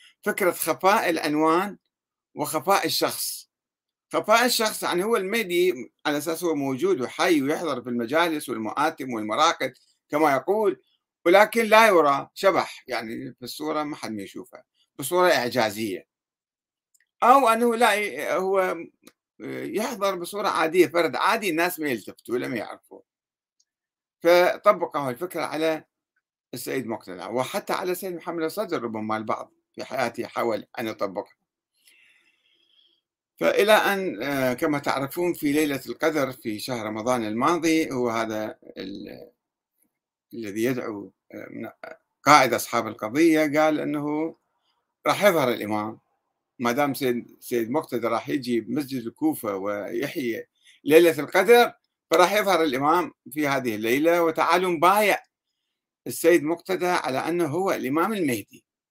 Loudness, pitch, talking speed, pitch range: -23 LUFS, 160 Hz, 120 wpm, 130-190 Hz